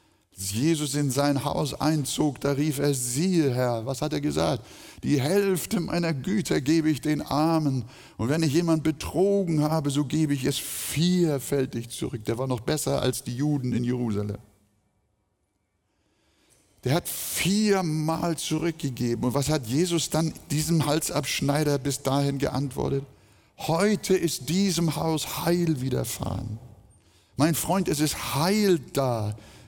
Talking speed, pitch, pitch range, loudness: 140 wpm, 145 Hz, 125-160 Hz, -26 LUFS